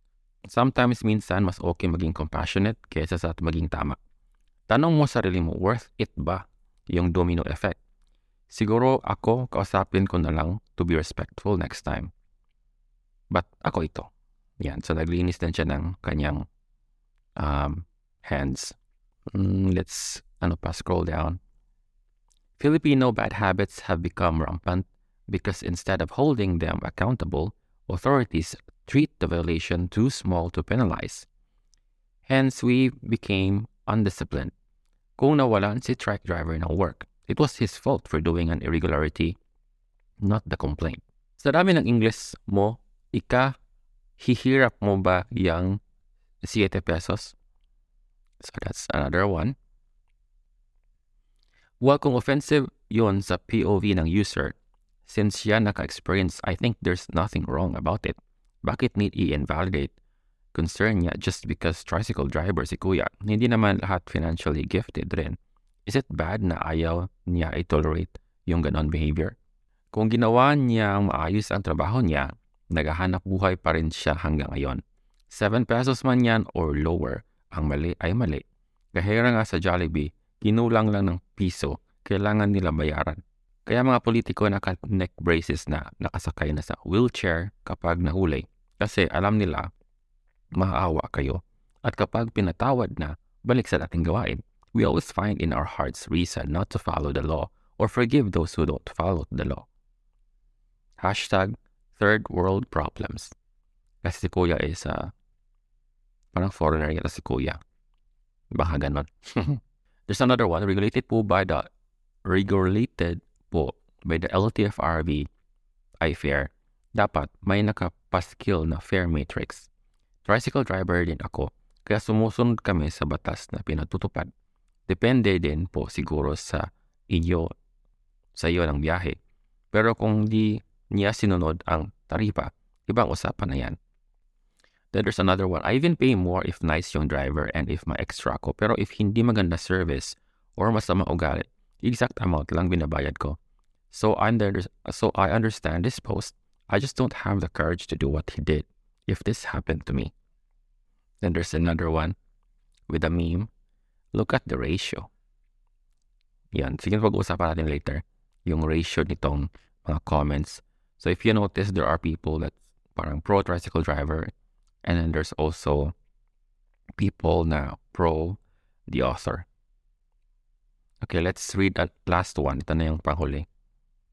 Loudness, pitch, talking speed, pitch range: -26 LUFS, 90 Hz, 140 wpm, 80-105 Hz